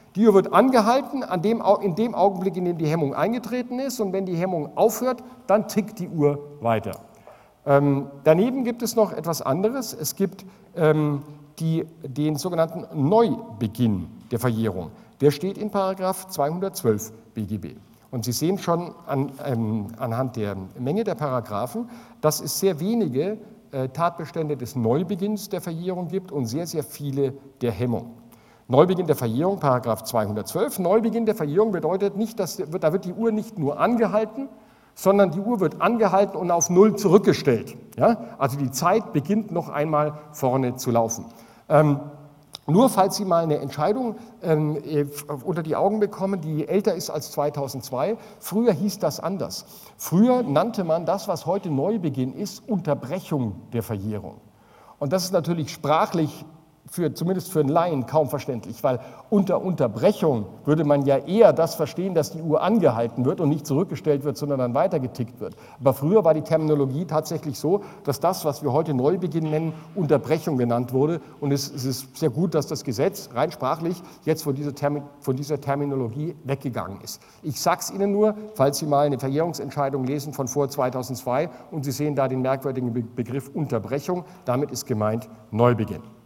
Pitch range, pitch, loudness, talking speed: 135-190 Hz, 155 Hz, -24 LUFS, 160 wpm